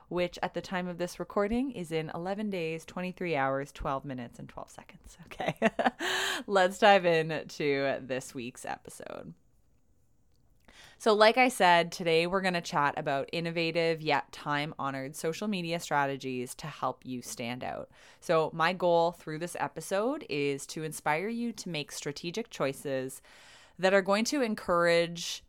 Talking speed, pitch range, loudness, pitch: 155 wpm, 145-185 Hz, -30 LUFS, 170 Hz